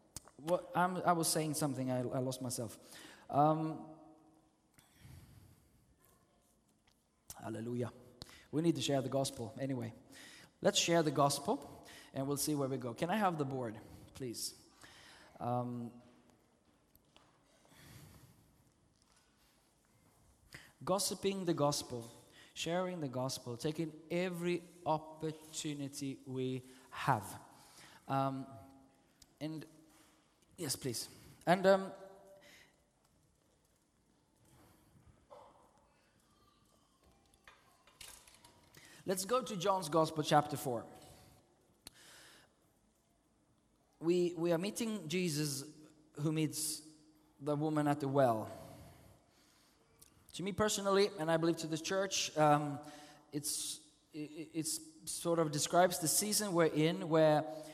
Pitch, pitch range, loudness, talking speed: 155 Hz, 135-170 Hz, -36 LUFS, 95 wpm